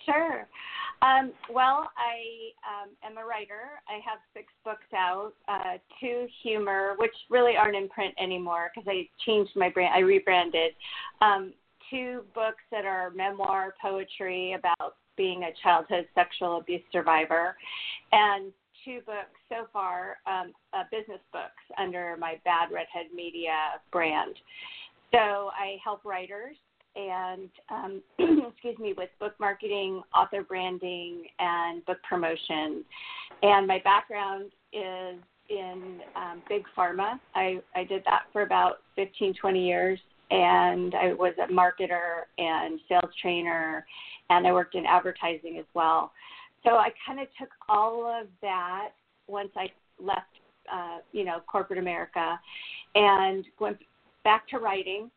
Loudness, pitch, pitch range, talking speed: -28 LUFS, 195 Hz, 180-220 Hz, 140 wpm